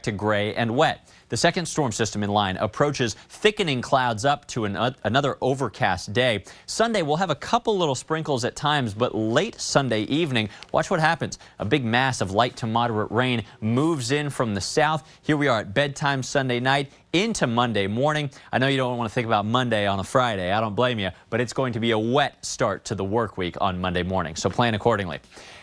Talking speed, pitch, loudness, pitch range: 220 wpm, 120 Hz, -24 LUFS, 105-140 Hz